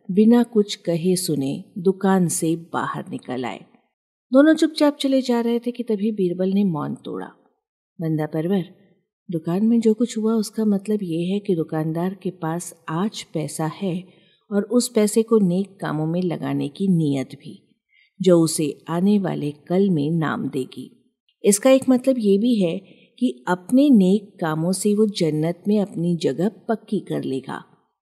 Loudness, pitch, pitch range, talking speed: -21 LUFS, 190 Hz, 165-220 Hz, 165 wpm